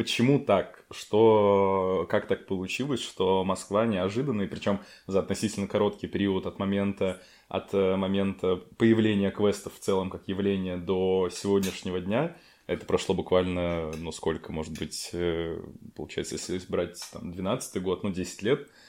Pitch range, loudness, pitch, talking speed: 90-100 Hz, -28 LUFS, 95 Hz, 140 wpm